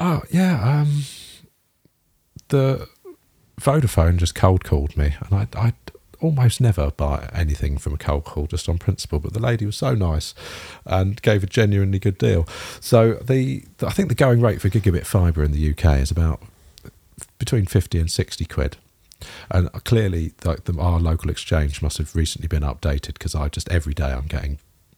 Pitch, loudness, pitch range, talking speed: 95 Hz, -21 LUFS, 80-115 Hz, 180 wpm